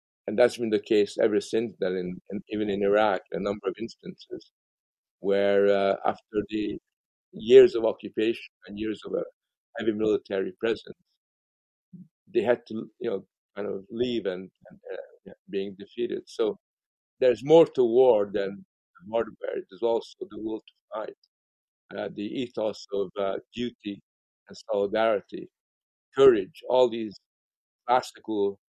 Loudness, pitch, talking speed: -26 LUFS, 115 Hz, 145 wpm